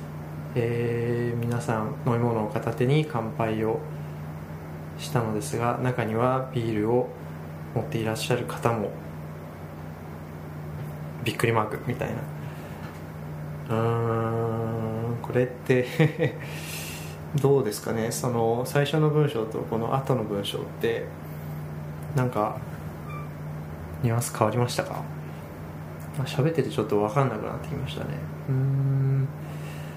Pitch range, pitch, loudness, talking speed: 75-120 Hz, 110 Hz, -28 LUFS, 235 characters per minute